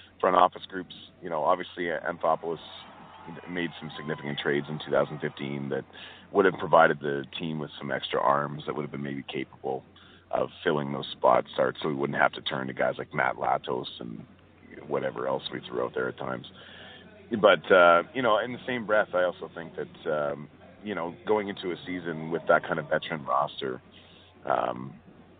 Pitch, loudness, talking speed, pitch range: 75 Hz, -28 LUFS, 190 wpm, 70-85 Hz